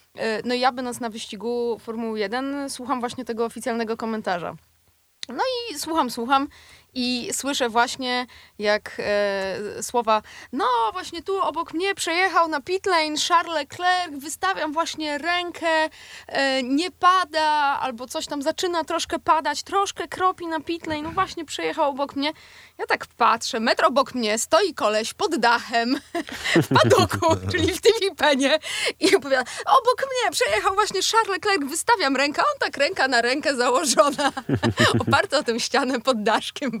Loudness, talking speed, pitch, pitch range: -22 LUFS, 145 wpm, 295 Hz, 245-345 Hz